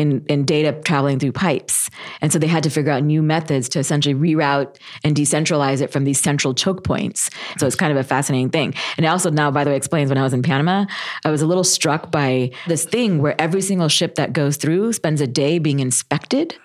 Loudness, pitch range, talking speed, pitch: -18 LUFS, 140-160 Hz, 240 wpm, 150 Hz